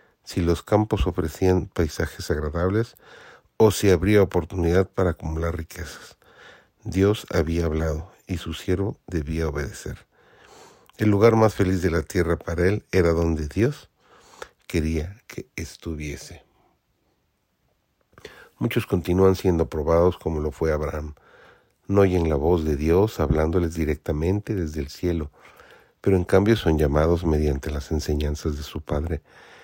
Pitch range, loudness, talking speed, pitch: 80-95 Hz, -23 LUFS, 135 wpm, 85 Hz